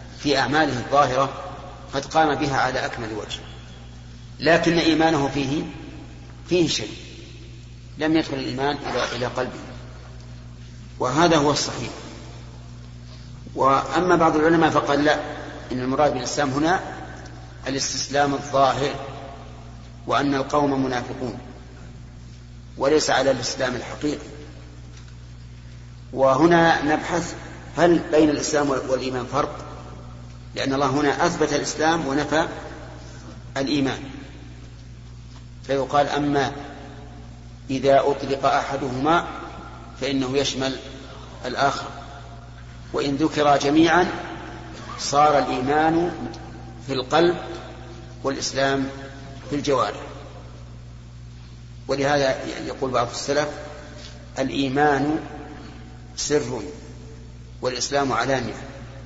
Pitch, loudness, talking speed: 135 Hz, -22 LUFS, 80 wpm